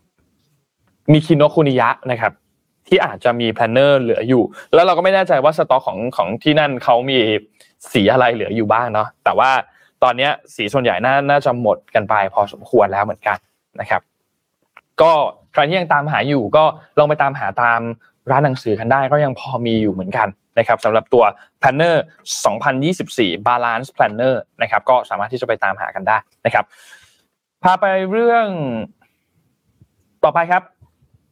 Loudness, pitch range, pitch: -16 LUFS, 115-150 Hz, 135 Hz